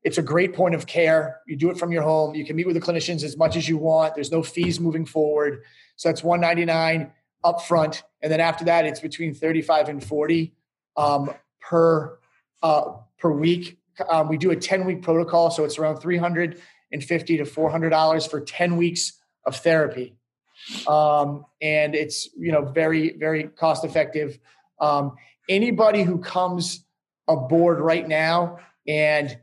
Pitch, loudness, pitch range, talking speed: 160 Hz, -22 LUFS, 150-170 Hz, 185 wpm